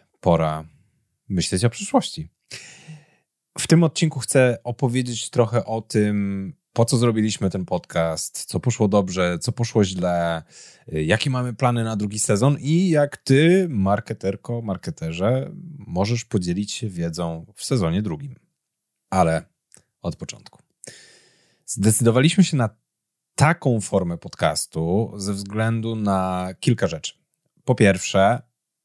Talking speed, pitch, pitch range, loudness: 120 wpm, 110 Hz, 95-130 Hz, -22 LUFS